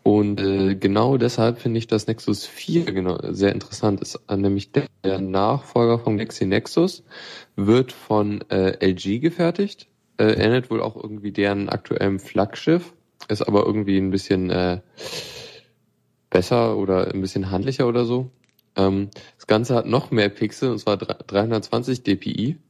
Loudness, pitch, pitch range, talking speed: -22 LUFS, 105 Hz, 100-120 Hz, 155 wpm